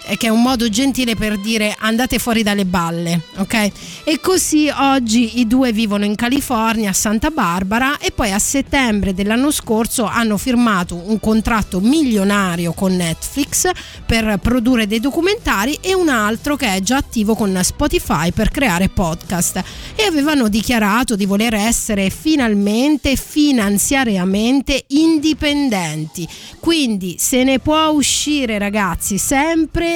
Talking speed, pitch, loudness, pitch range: 135 wpm, 230 Hz, -16 LUFS, 205-275 Hz